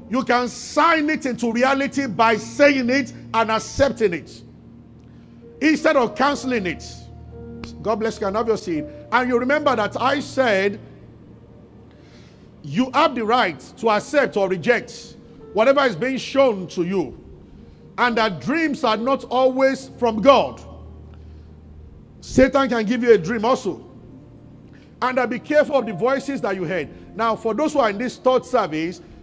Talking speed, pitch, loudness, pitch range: 160 wpm, 240 Hz, -20 LUFS, 205-270 Hz